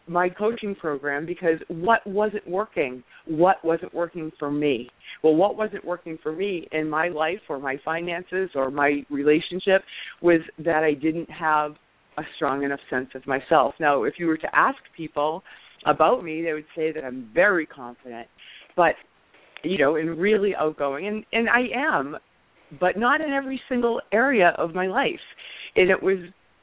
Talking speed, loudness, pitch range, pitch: 170 wpm, -24 LUFS, 150-190 Hz, 165 Hz